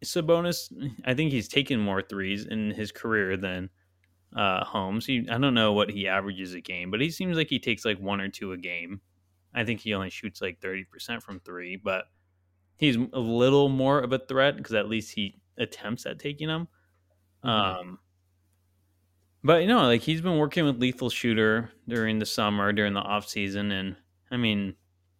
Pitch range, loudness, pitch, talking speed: 95-125 Hz, -27 LUFS, 105 Hz, 195 wpm